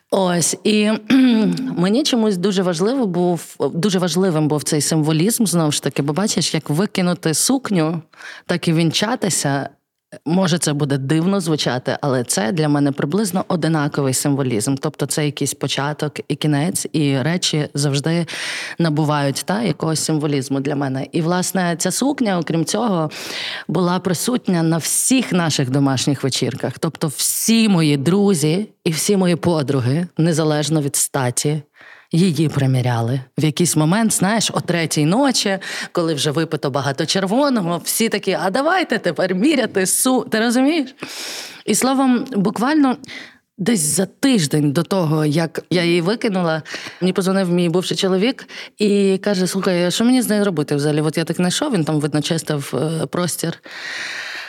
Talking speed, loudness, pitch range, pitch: 145 wpm, -18 LUFS, 150-200 Hz, 170 Hz